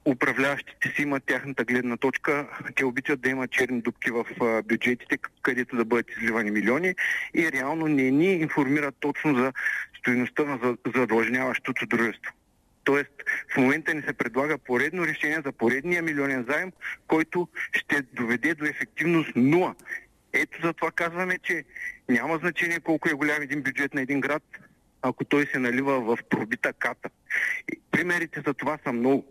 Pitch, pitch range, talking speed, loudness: 140 Hz, 125-150 Hz, 150 wpm, -26 LUFS